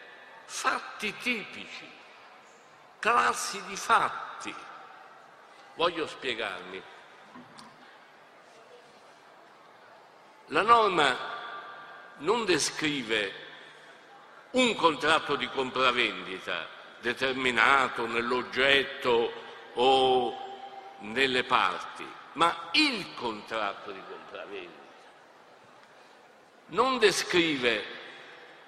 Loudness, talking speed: -27 LUFS, 55 wpm